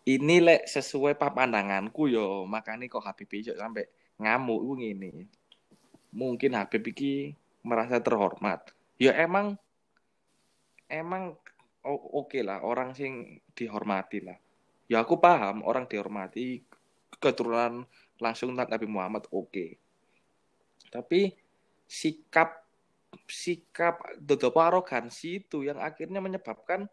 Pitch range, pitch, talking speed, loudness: 115-165 Hz, 135 Hz, 105 wpm, -29 LUFS